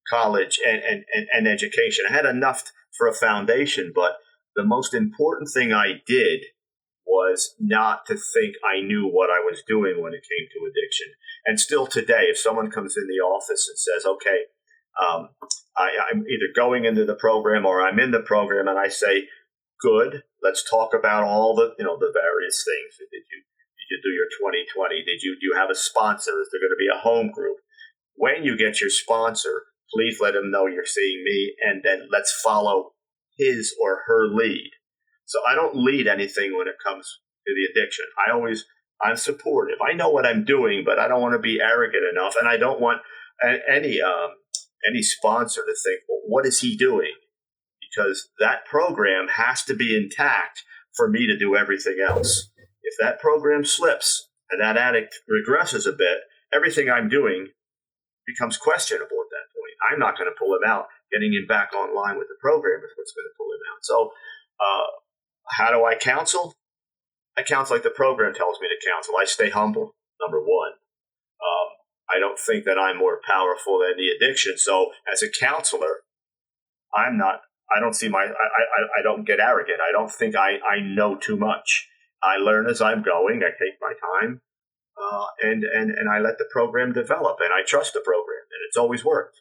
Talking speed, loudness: 195 wpm, -21 LUFS